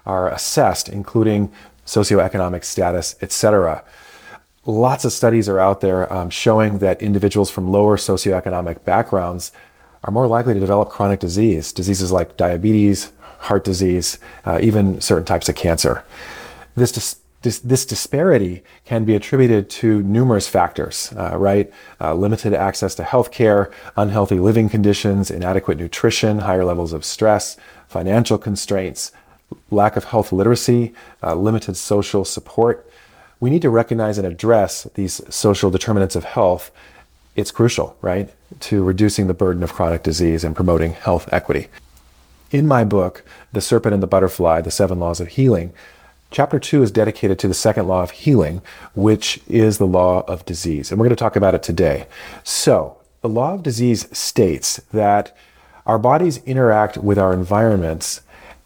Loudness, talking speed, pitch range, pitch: -18 LUFS, 155 wpm, 90-110 Hz, 100 Hz